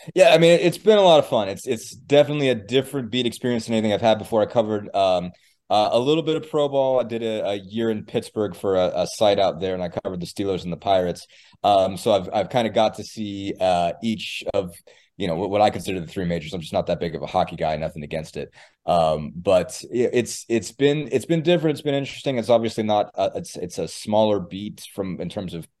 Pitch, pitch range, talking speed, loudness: 110 Hz, 95-135 Hz, 255 wpm, -22 LUFS